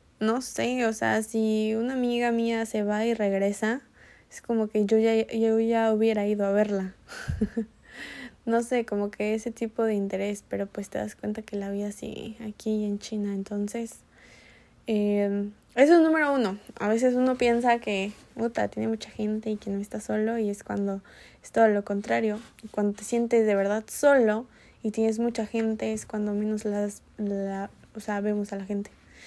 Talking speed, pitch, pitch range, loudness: 185 wpm, 215 Hz, 205-230 Hz, -27 LUFS